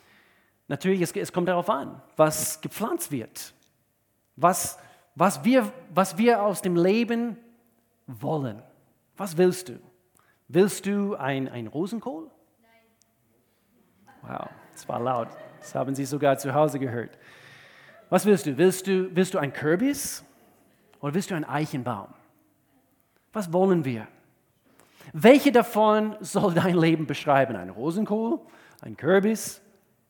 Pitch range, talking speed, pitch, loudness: 140-205 Hz, 130 wpm, 180 Hz, -25 LUFS